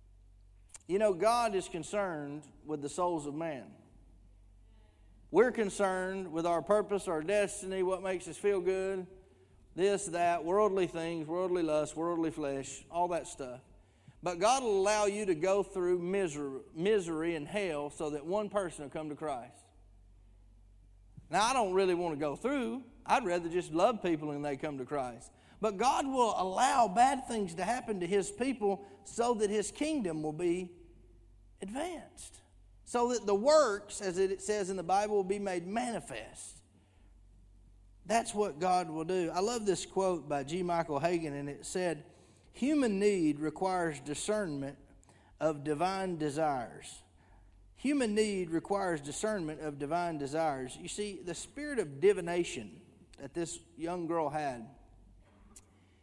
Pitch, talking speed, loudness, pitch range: 170 Hz, 155 wpm, -33 LUFS, 140-200 Hz